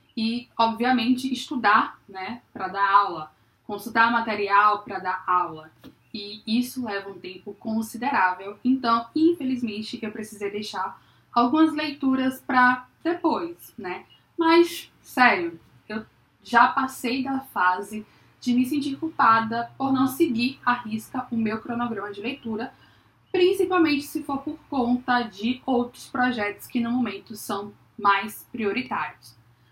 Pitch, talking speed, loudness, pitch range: 235 Hz, 125 wpm, -24 LUFS, 205-260 Hz